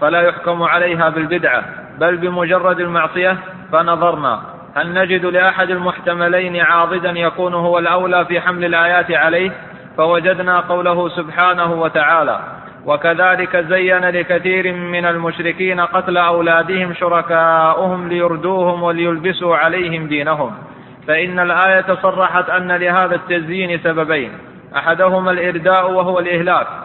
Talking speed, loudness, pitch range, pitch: 105 wpm, -15 LUFS, 170-185 Hz, 175 Hz